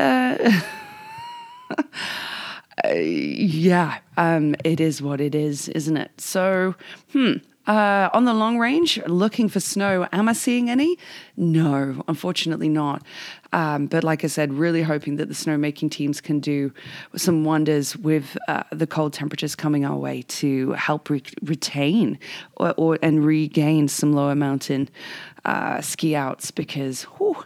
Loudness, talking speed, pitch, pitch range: -22 LUFS, 145 wpm, 160 Hz, 150-200 Hz